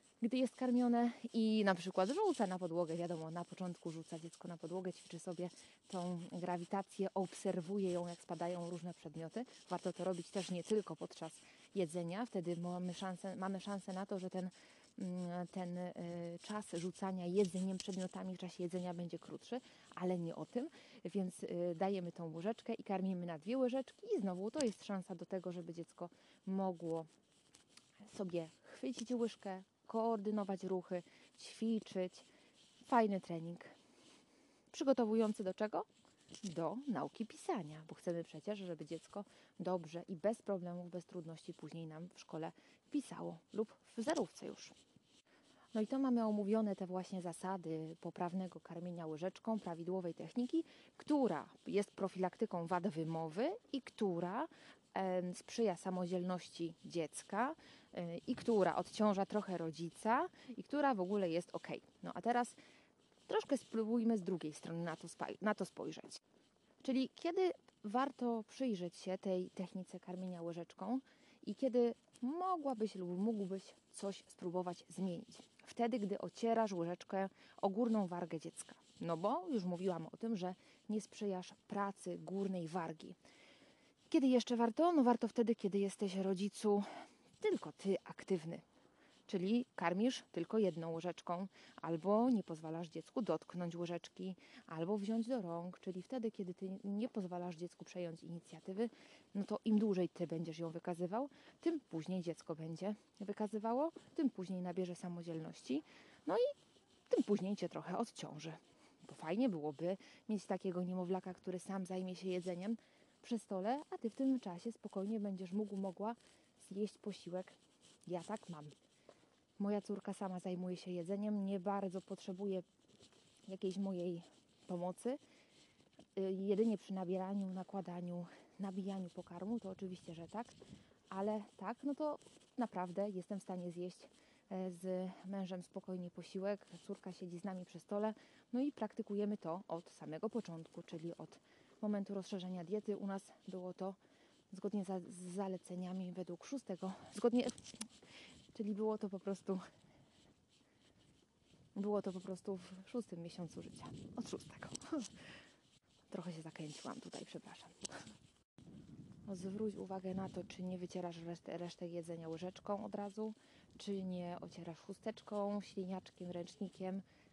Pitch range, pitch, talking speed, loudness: 180-220 Hz, 190 Hz, 140 wpm, -42 LUFS